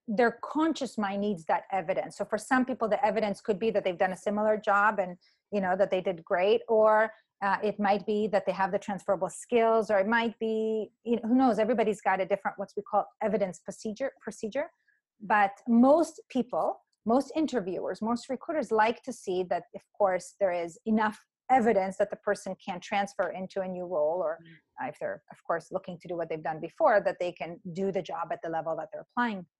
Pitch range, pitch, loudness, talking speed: 190-225 Hz, 205 Hz, -29 LUFS, 215 wpm